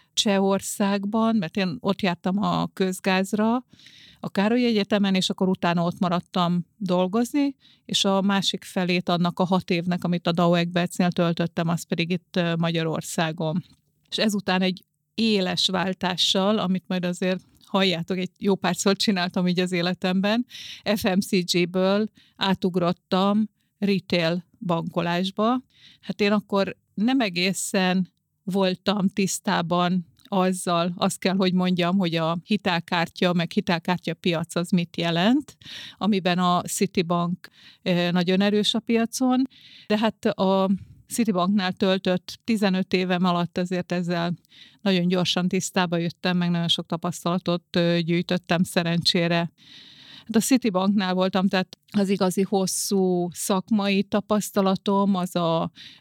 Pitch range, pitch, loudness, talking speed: 175-200 Hz, 185 Hz, -24 LUFS, 120 wpm